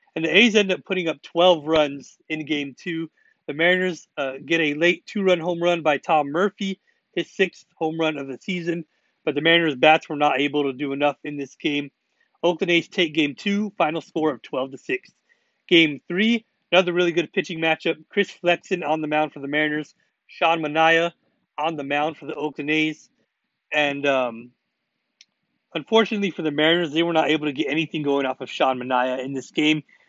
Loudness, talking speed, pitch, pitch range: -22 LUFS, 200 wpm, 160 Hz, 150-175 Hz